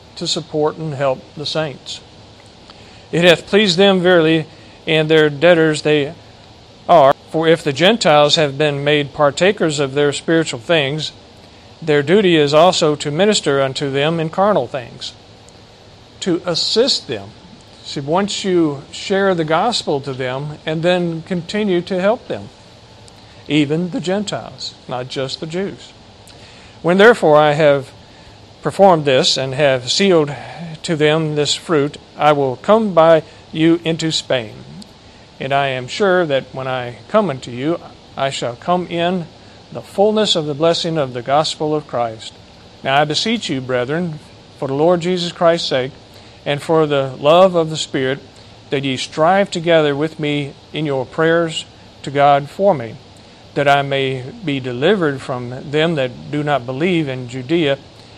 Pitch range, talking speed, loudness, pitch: 130-165 Hz, 155 wpm, -16 LUFS, 150 Hz